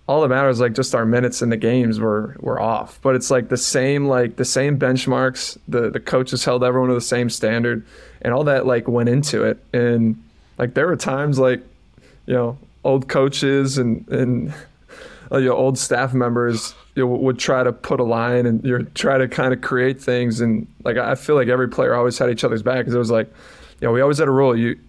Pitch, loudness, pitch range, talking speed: 125 Hz, -19 LUFS, 120-130 Hz, 230 wpm